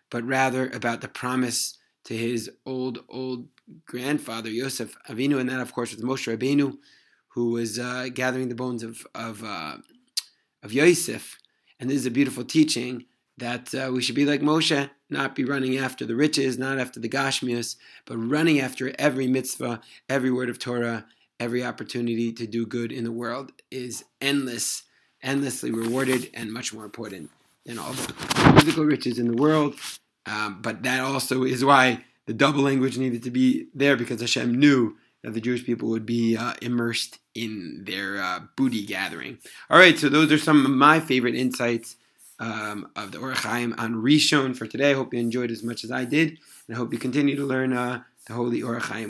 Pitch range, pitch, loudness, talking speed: 120-135 Hz, 125 Hz, -24 LUFS, 185 wpm